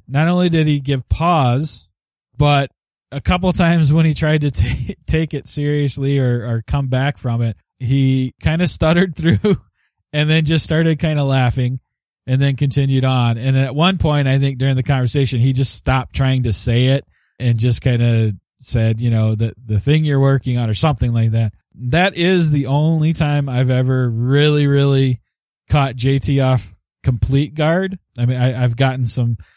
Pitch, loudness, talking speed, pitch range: 135 Hz, -16 LUFS, 190 wpm, 120-150 Hz